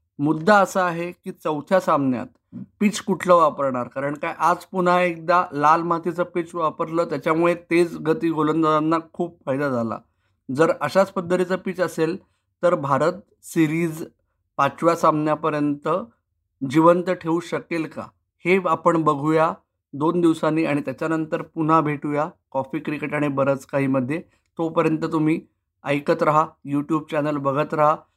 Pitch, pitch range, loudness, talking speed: 160 Hz, 145-170 Hz, -22 LUFS, 130 wpm